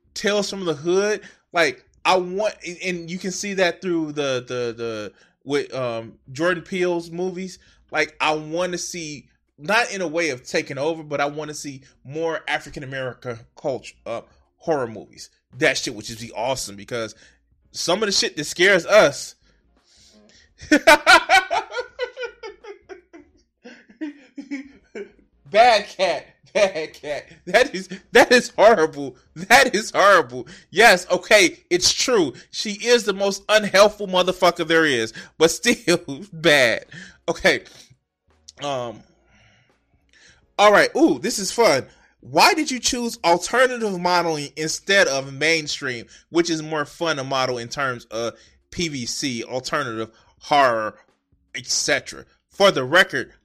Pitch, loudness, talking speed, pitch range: 175 Hz, -20 LUFS, 130 wpm, 145-215 Hz